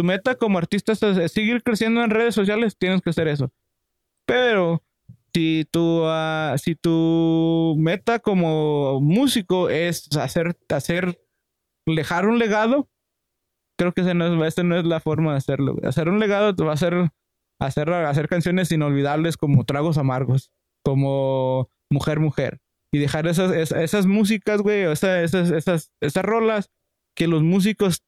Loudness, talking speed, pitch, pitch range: -21 LUFS, 155 wpm, 165 Hz, 150-190 Hz